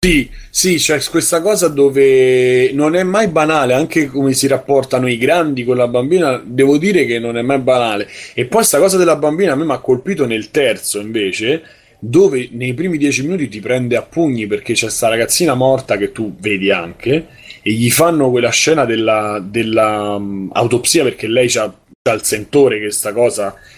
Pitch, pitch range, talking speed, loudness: 130 Hz, 110-150 Hz, 190 wpm, -14 LUFS